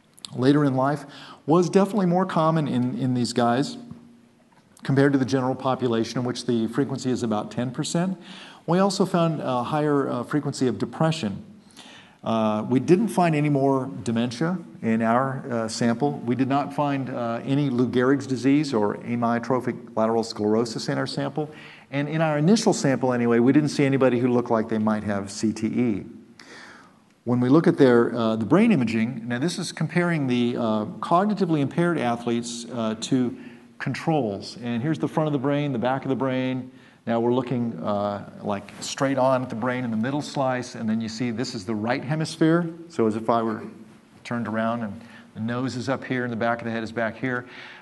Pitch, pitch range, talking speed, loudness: 130 Hz, 115-145 Hz, 195 wpm, -24 LUFS